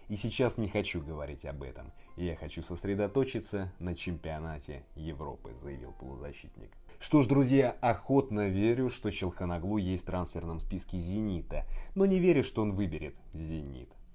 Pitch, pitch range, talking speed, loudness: 90 Hz, 80-110 Hz, 145 wpm, -32 LUFS